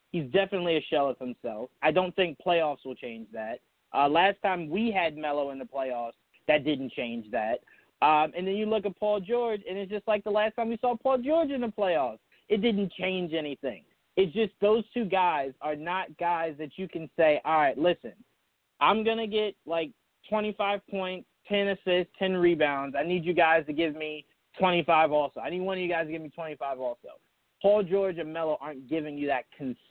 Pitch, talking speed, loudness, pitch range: 175 Hz, 215 wpm, -28 LUFS, 150-205 Hz